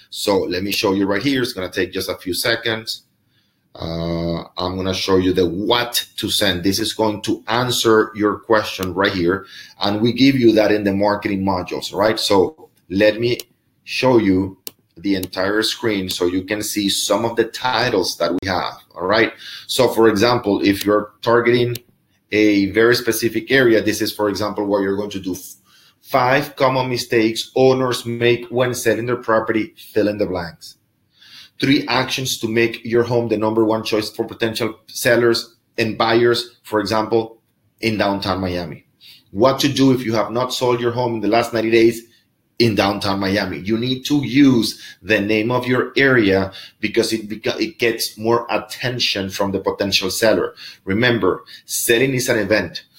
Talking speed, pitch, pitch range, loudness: 180 wpm, 110 Hz, 100-120 Hz, -18 LUFS